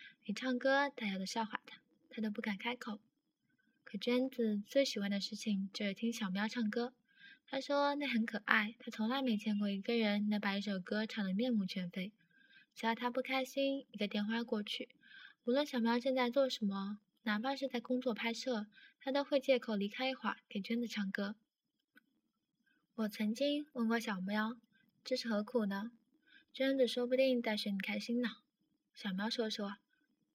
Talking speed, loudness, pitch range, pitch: 255 characters per minute, -37 LUFS, 210-255 Hz, 230 Hz